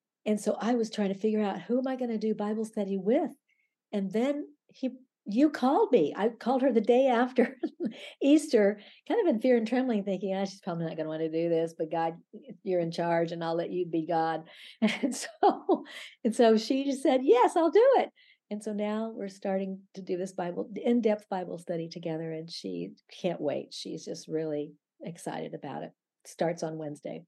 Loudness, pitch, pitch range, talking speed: -29 LUFS, 210 Hz, 175-255 Hz, 205 wpm